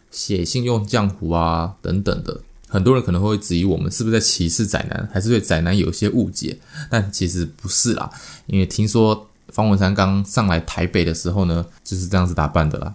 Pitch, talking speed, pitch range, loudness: 95 Hz, 310 characters per minute, 90-110 Hz, -19 LUFS